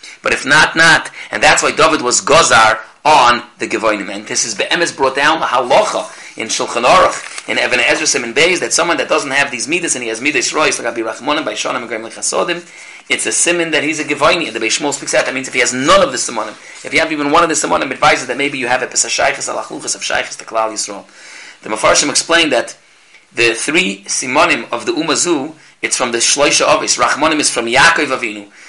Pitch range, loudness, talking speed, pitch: 115-160 Hz, -13 LUFS, 220 wpm, 145 Hz